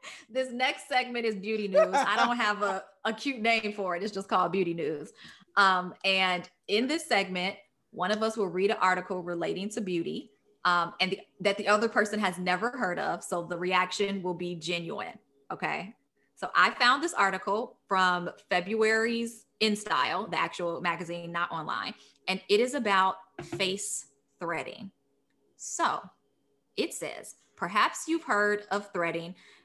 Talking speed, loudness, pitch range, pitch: 165 wpm, -29 LUFS, 180-220 Hz, 195 Hz